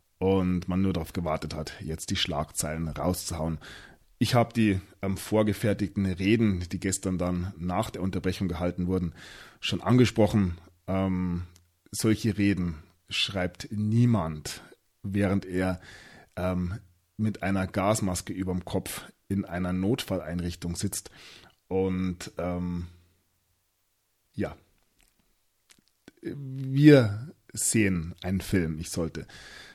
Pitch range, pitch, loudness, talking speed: 90-100 Hz, 95 Hz, -28 LUFS, 105 wpm